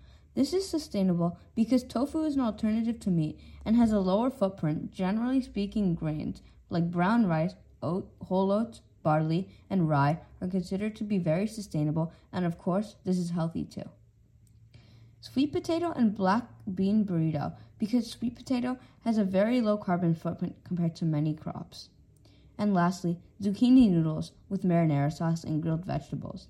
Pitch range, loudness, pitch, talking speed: 165-225 Hz, -29 LUFS, 190 Hz, 155 wpm